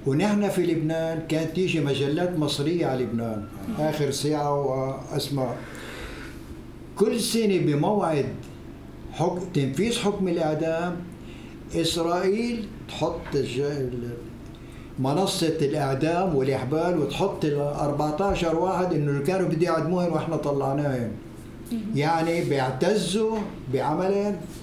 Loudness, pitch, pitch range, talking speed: -25 LUFS, 160 Hz, 140-180 Hz, 95 wpm